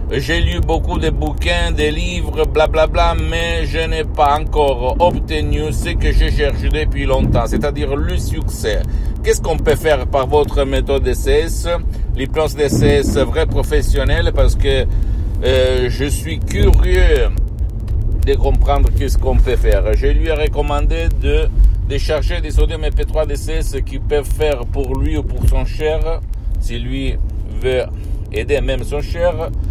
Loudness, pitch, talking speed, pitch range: -17 LUFS, 90 Hz, 155 wpm, 80-120 Hz